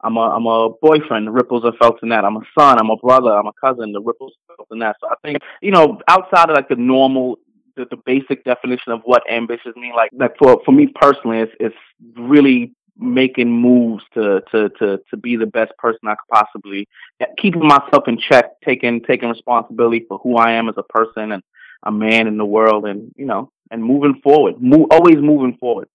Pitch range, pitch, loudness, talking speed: 115-140 Hz, 120 Hz, -14 LUFS, 220 wpm